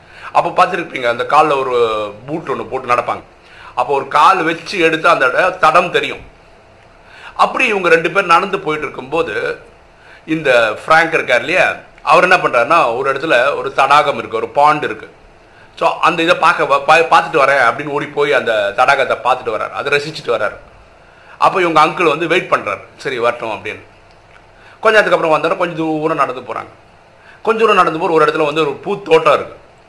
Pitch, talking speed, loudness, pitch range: 155 Hz, 160 wpm, -13 LUFS, 135-170 Hz